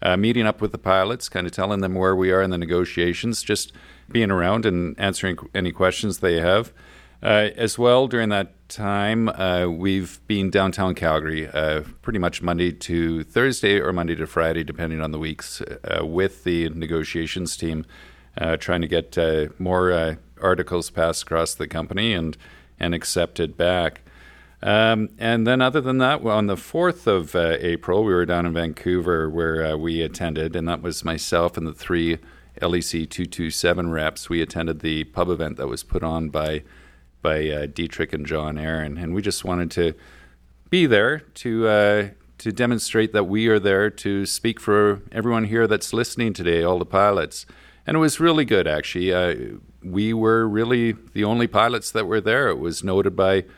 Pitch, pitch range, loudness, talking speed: 90 Hz, 80-105 Hz, -22 LUFS, 185 wpm